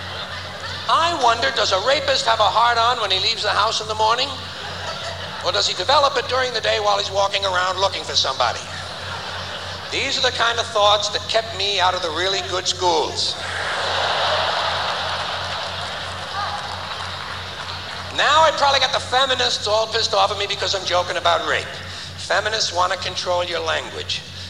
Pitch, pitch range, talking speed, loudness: 220 Hz, 200-250 Hz, 170 wpm, -20 LUFS